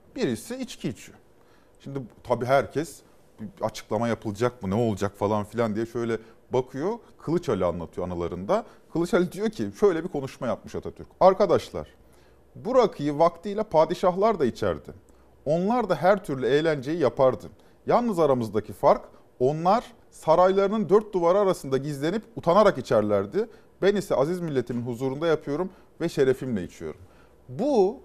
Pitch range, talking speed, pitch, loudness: 110-180 Hz, 135 wpm, 135 Hz, -25 LUFS